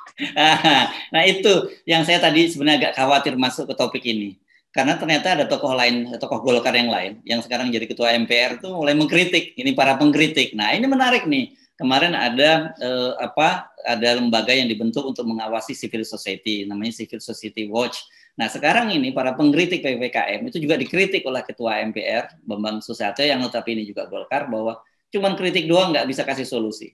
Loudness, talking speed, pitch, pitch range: -19 LUFS, 180 wpm, 125 Hz, 115-160 Hz